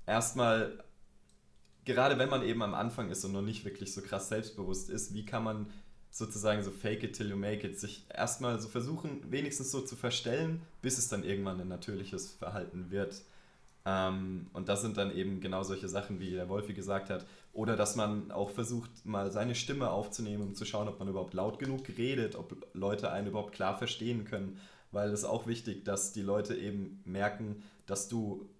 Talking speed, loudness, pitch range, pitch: 195 wpm, -36 LUFS, 100-115 Hz, 105 Hz